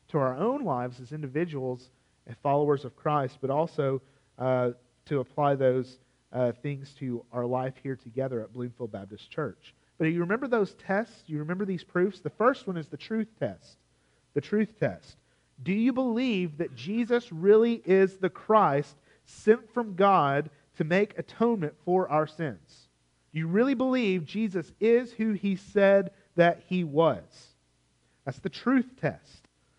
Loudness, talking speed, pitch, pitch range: -28 LUFS, 165 wpm, 160 Hz, 130-200 Hz